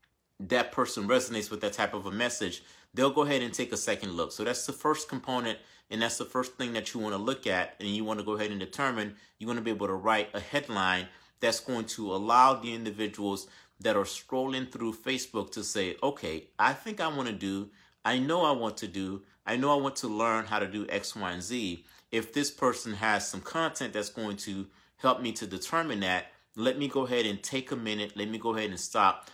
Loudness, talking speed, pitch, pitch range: -31 LUFS, 240 wpm, 110 Hz, 105-125 Hz